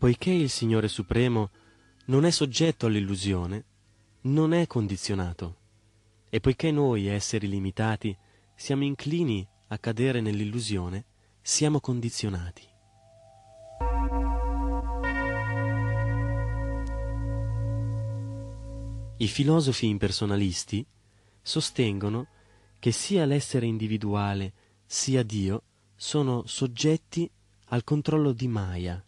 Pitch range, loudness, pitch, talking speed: 105-130 Hz, -28 LUFS, 110 Hz, 80 wpm